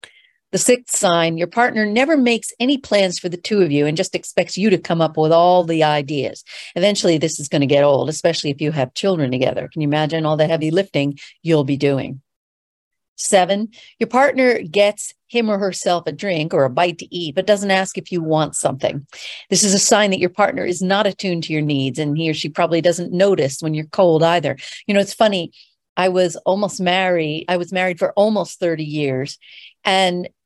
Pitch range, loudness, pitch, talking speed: 155-200 Hz, -18 LUFS, 180 Hz, 215 wpm